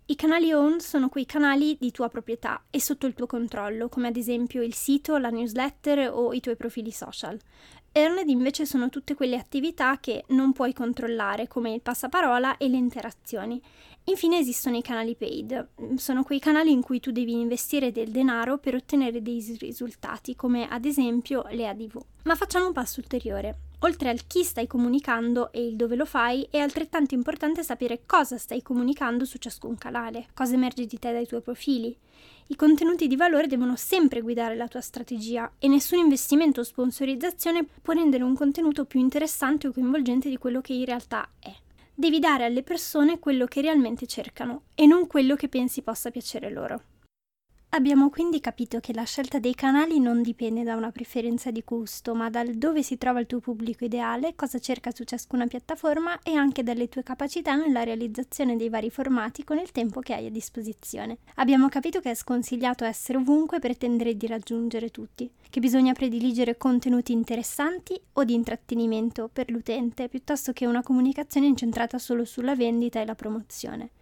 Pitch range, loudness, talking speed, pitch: 235-280 Hz, -26 LUFS, 180 wpm, 250 Hz